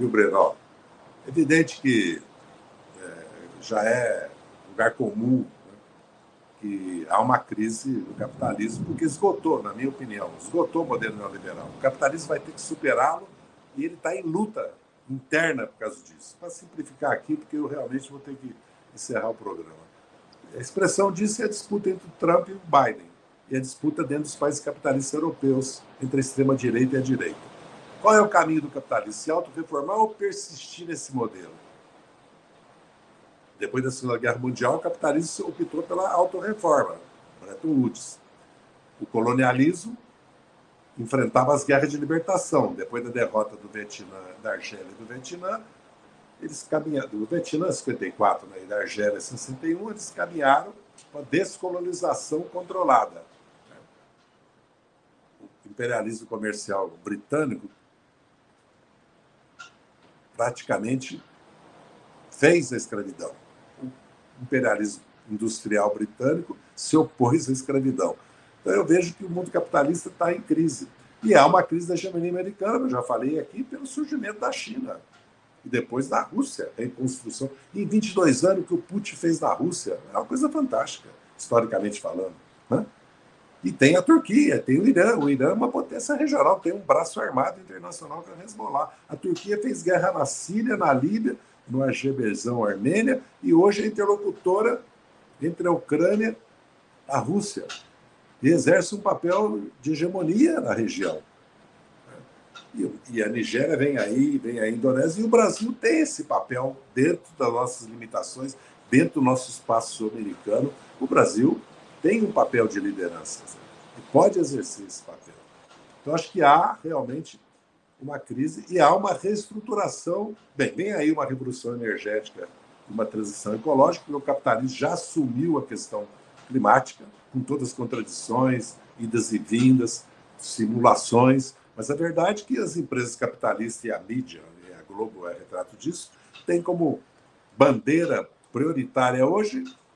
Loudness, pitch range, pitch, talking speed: -25 LUFS, 125-195 Hz, 155 Hz, 150 wpm